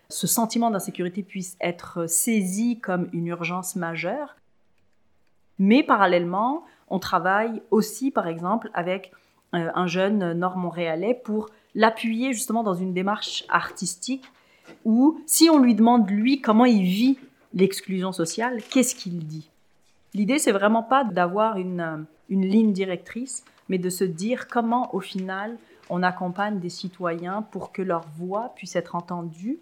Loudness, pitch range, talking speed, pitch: -24 LUFS, 180-235 Hz, 140 wpm, 195 Hz